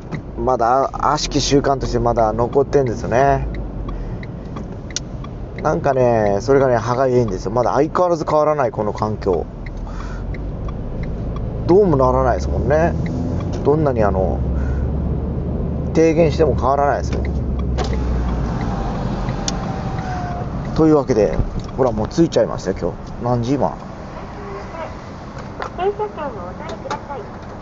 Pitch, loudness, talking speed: 120 Hz, -19 LUFS, 250 characters per minute